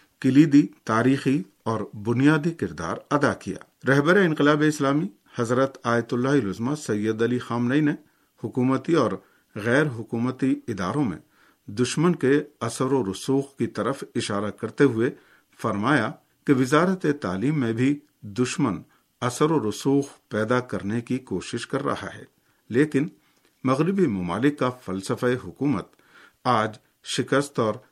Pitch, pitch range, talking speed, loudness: 130 Hz, 115-145 Hz, 130 wpm, -24 LUFS